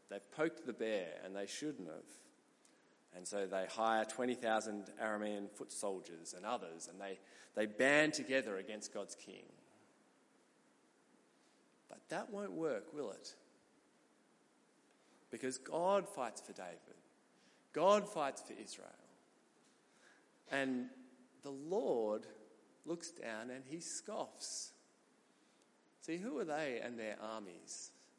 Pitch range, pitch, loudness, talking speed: 100-140 Hz, 110 Hz, -41 LUFS, 120 wpm